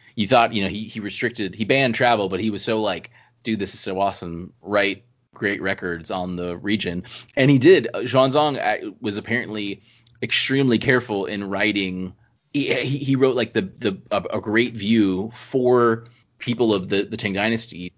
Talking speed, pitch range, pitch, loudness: 175 wpm, 100-125 Hz, 110 Hz, -21 LUFS